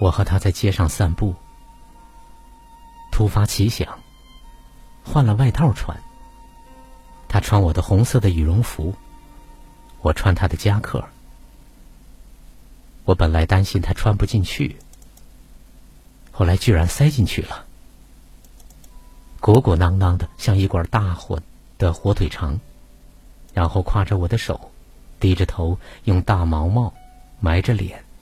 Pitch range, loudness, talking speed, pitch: 90-115 Hz, -20 LUFS, 175 characters per minute, 100 Hz